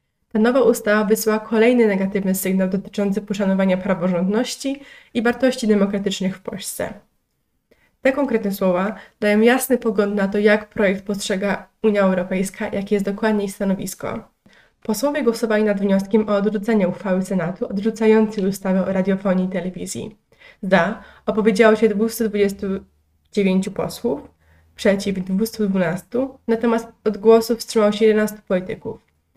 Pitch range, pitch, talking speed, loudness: 195-225 Hz, 210 Hz, 125 wpm, -20 LUFS